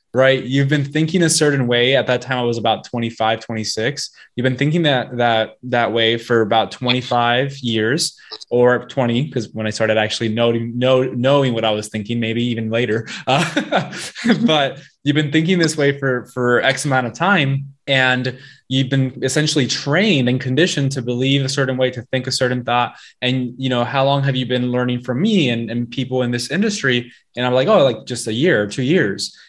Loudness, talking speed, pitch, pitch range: -18 LUFS, 205 wpm, 125 Hz, 120-140 Hz